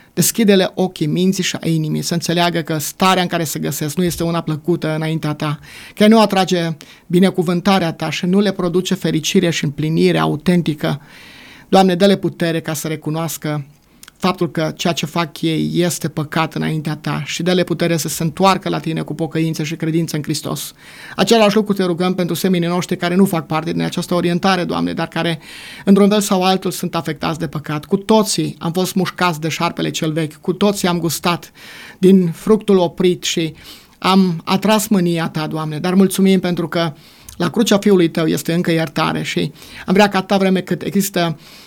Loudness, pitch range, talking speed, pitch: -17 LUFS, 160-185 Hz, 185 wpm, 170 Hz